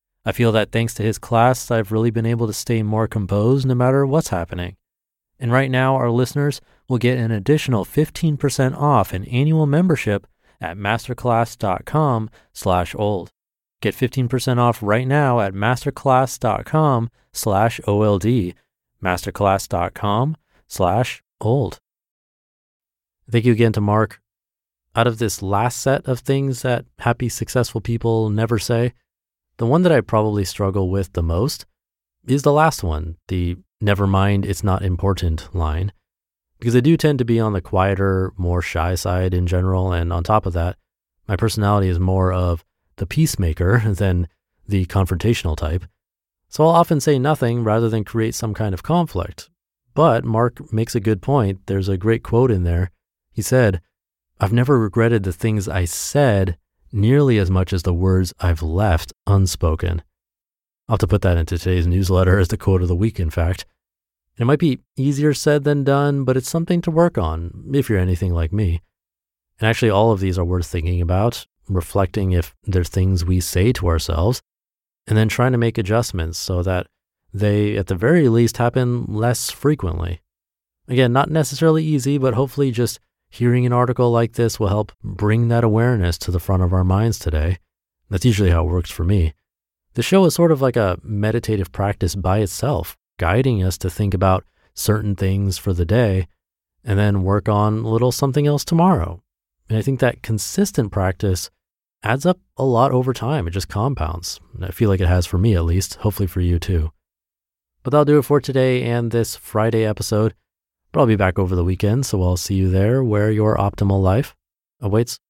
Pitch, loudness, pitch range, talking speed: 105 Hz, -19 LUFS, 90-120 Hz, 180 wpm